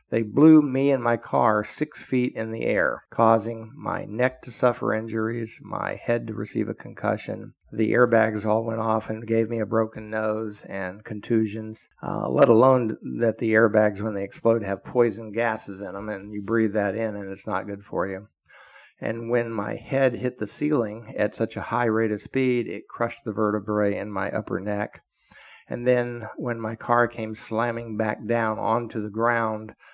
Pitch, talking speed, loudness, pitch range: 110 Hz, 190 wpm, -25 LUFS, 105-120 Hz